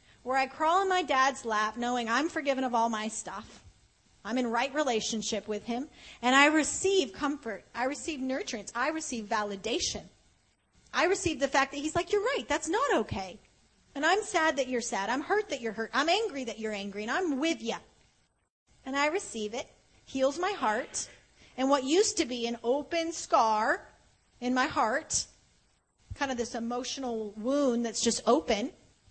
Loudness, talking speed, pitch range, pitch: -30 LUFS, 180 wpm, 230-310 Hz, 260 Hz